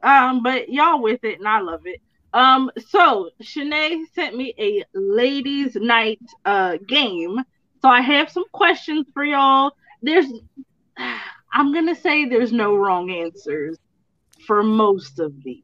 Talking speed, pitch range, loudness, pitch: 145 wpm, 215-300 Hz, -19 LUFS, 260 Hz